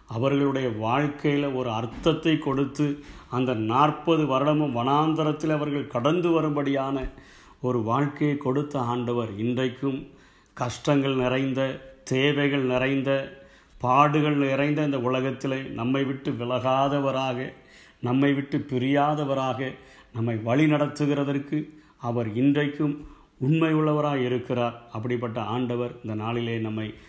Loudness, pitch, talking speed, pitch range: -25 LUFS, 135 Hz, 95 wpm, 125-145 Hz